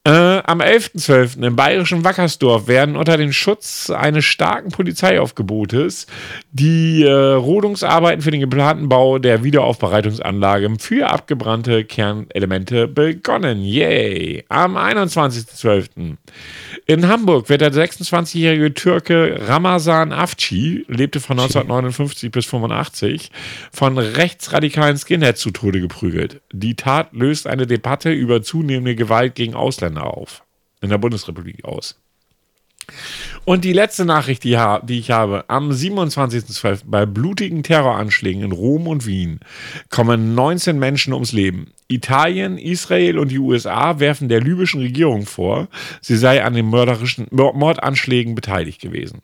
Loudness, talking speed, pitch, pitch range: -16 LUFS, 125 wpm, 135 Hz, 115-160 Hz